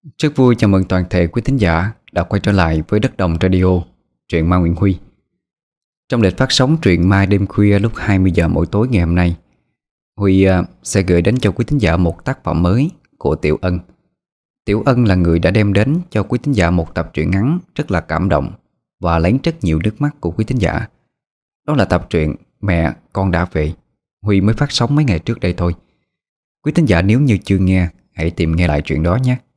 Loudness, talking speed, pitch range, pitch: -15 LUFS, 225 wpm, 85-125 Hz, 95 Hz